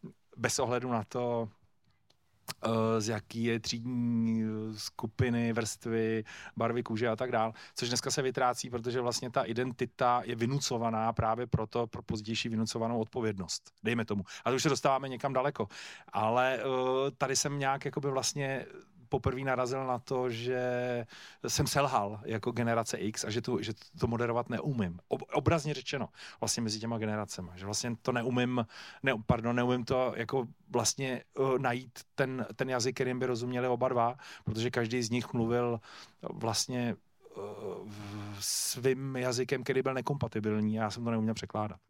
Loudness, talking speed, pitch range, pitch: -33 LUFS, 150 wpm, 110-130 Hz, 120 Hz